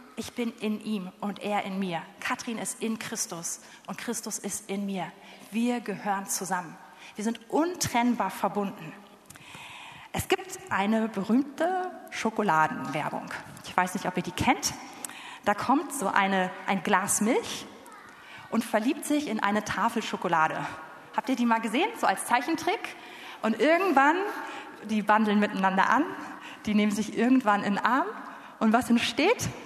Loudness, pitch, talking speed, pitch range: -28 LUFS, 215 Hz, 150 wpm, 195-255 Hz